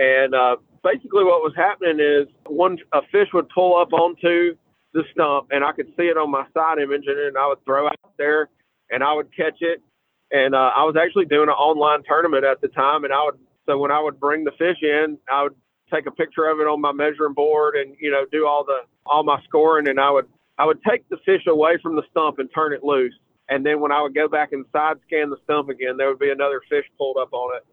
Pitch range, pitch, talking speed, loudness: 140-160 Hz, 150 Hz, 255 wpm, -20 LUFS